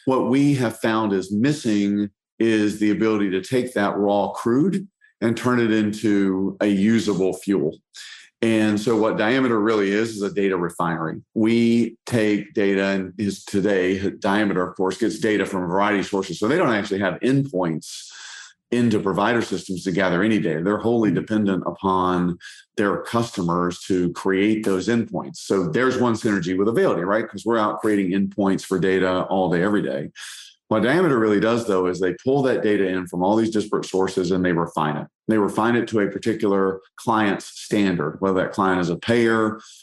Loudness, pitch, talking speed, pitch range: -21 LUFS, 100 Hz, 185 wpm, 95-110 Hz